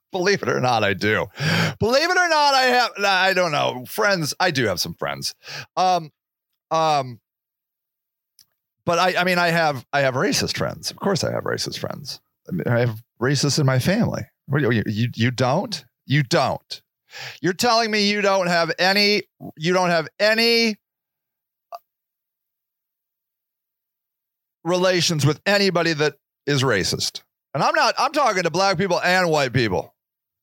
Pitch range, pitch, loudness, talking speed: 140-195 Hz, 170 Hz, -20 LUFS, 160 wpm